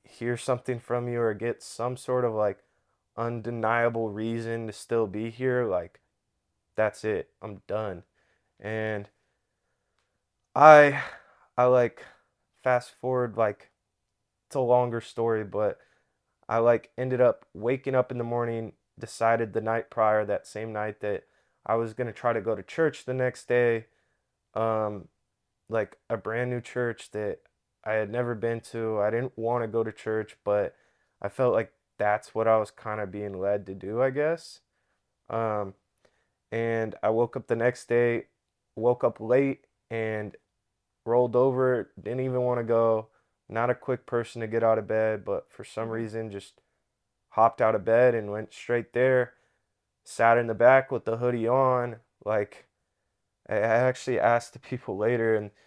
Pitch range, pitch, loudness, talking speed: 110-125 Hz, 115 Hz, -27 LUFS, 165 wpm